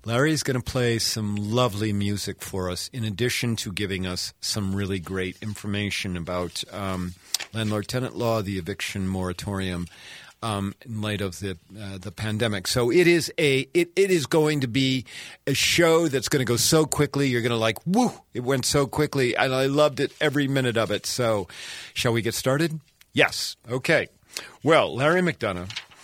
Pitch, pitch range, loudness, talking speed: 115 Hz, 100-135 Hz, -24 LUFS, 180 wpm